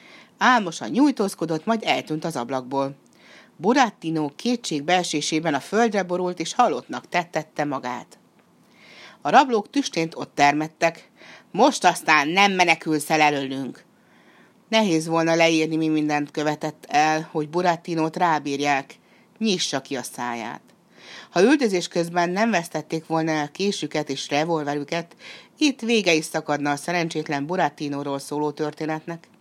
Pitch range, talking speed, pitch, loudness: 150-195 Hz, 120 wpm, 165 Hz, -22 LUFS